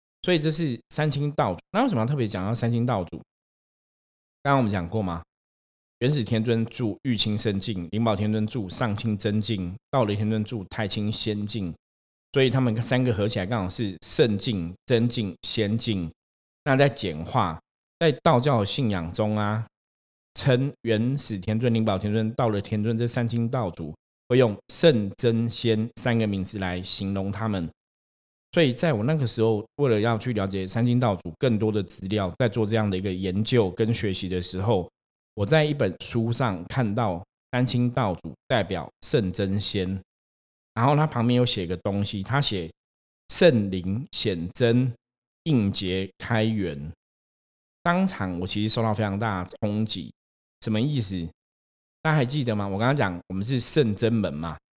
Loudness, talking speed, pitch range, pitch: -25 LUFS, 250 characters per minute, 95-120 Hz, 110 Hz